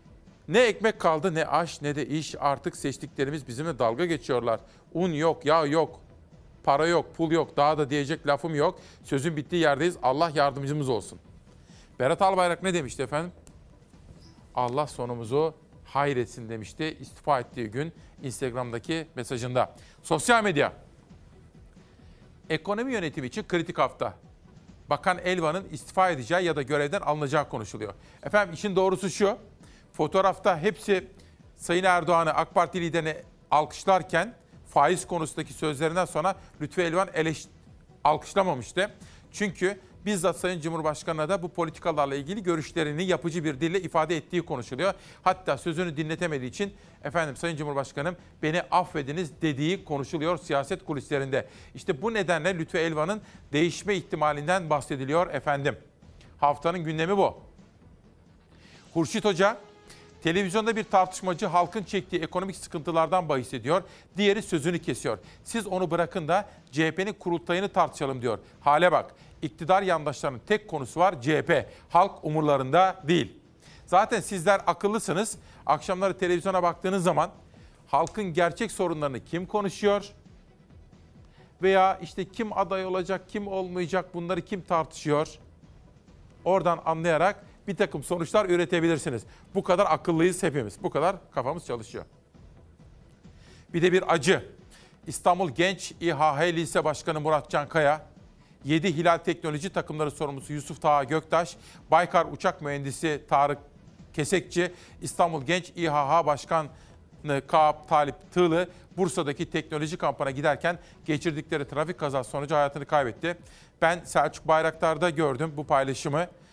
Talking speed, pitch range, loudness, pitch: 125 wpm, 150-185 Hz, -27 LUFS, 165 Hz